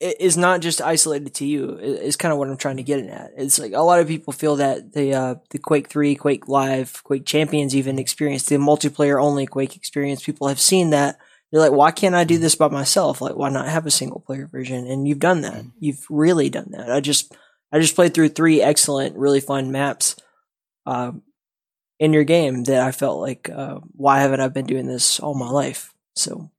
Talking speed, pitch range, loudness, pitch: 220 wpm, 135-155 Hz, -19 LUFS, 145 Hz